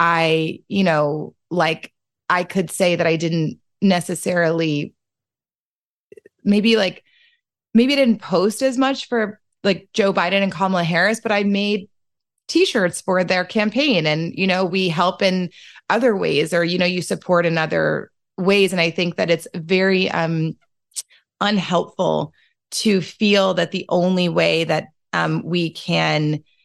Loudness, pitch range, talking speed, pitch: -19 LUFS, 170-205 Hz, 150 wpm, 180 Hz